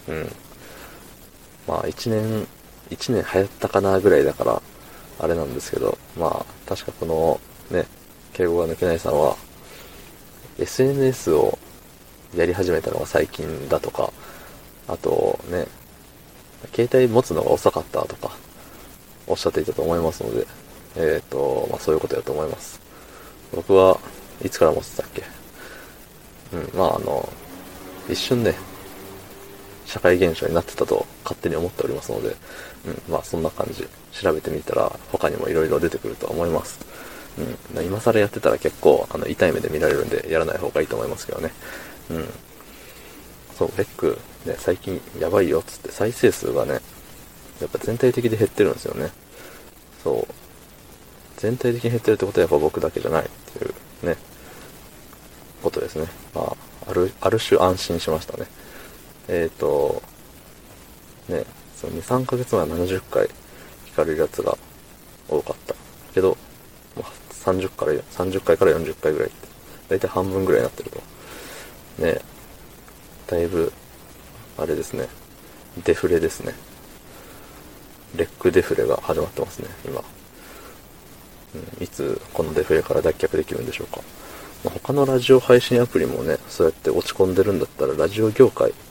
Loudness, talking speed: -22 LUFS, 300 characters per minute